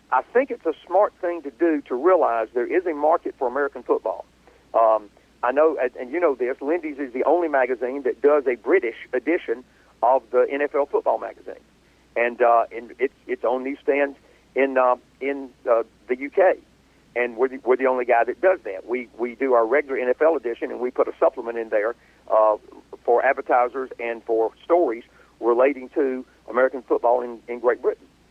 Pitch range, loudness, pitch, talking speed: 120-170 Hz, -22 LUFS, 130 Hz, 195 wpm